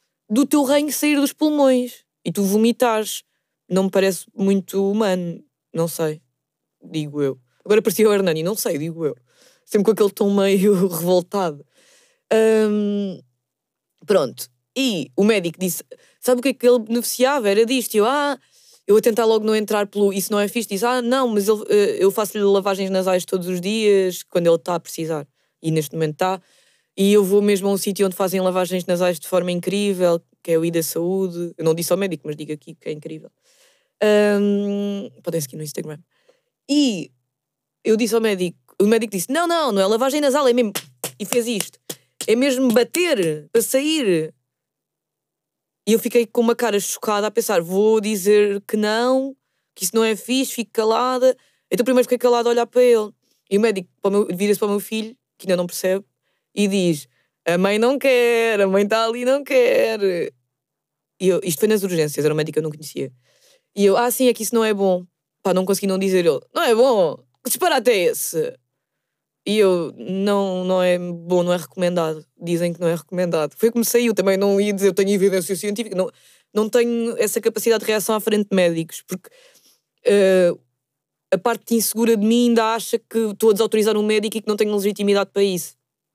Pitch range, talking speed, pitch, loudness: 180-235 Hz, 205 wpm, 205 Hz, -19 LUFS